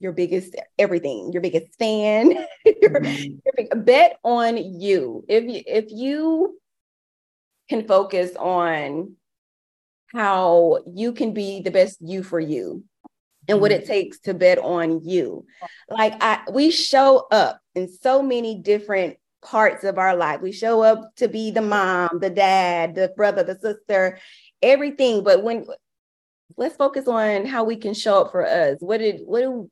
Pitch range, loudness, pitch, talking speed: 185-245 Hz, -20 LUFS, 210 Hz, 155 wpm